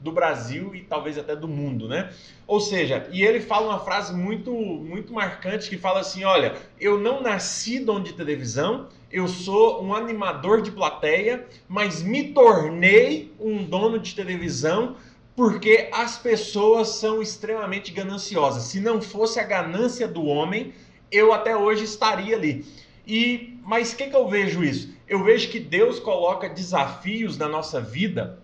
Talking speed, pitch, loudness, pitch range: 160 wpm, 205 Hz, -23 LUFS, 180-225 Hz